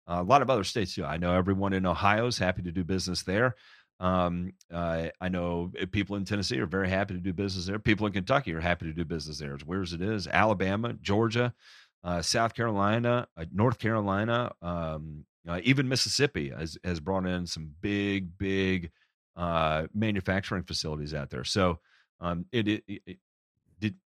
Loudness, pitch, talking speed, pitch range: -29 LUFS, 95 Hz, 180 wpm, 85-105 Hz